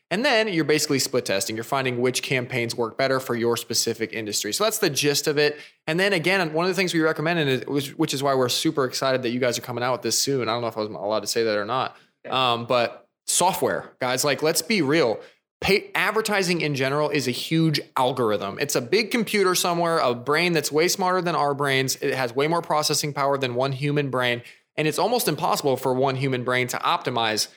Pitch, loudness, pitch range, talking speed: 140 Hz, -23 LUFS, 125-160 Hz, 235 wpm